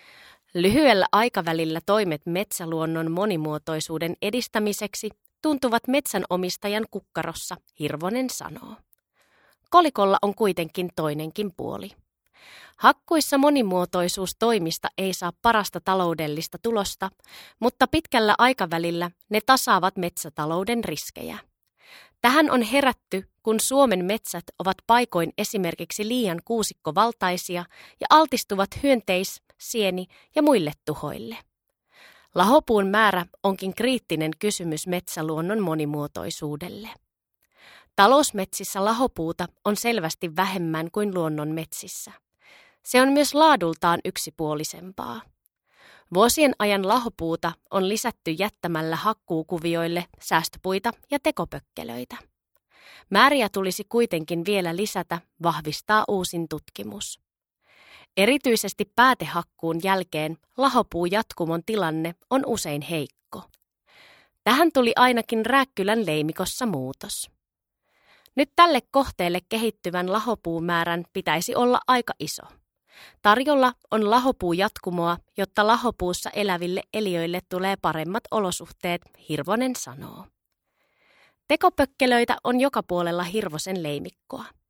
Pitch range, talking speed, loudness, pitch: 170-230 Hz, 90 wpm, -23 LUFS, 195 Hz